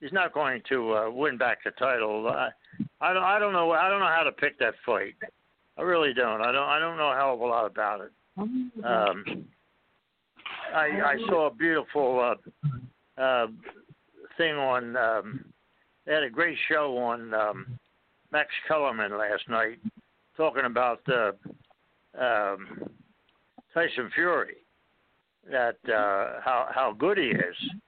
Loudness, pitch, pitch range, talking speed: -27 LUFS, 150 Hz, 125-170 Hz, 160 wpm